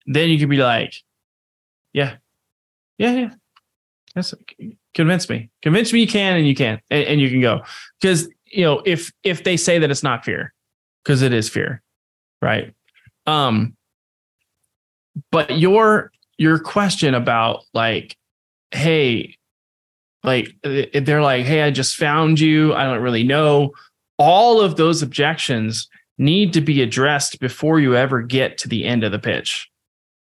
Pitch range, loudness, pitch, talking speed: 115-160 Hz, -17 LUFS, 145 Hz, 150 wpm